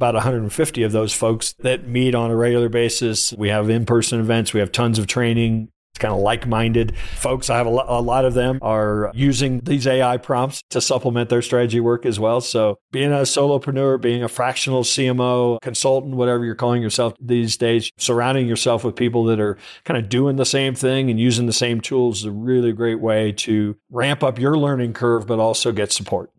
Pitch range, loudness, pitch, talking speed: 115-130 Hz, -19 LUFS, 120 Hz, 215 wpm